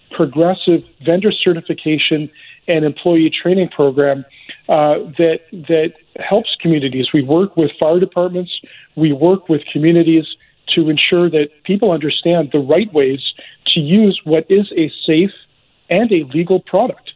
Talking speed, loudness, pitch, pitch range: 135 wpm, -14 LUFS, 165 Hz, 155-180 Hz